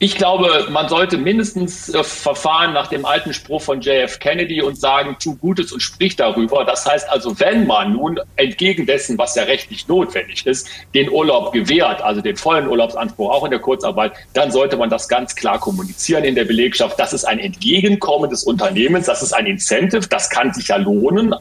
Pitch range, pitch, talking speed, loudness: 150-195 Hz, 185 Hz, 195 wpm, -16 LUFS